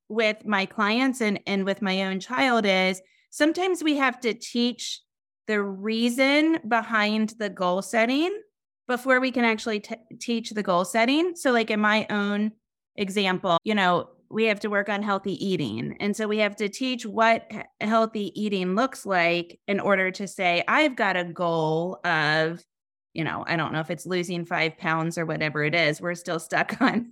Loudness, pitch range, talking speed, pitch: -24 LUFS, 185-230 Hz, 185 wpm, 210 Hz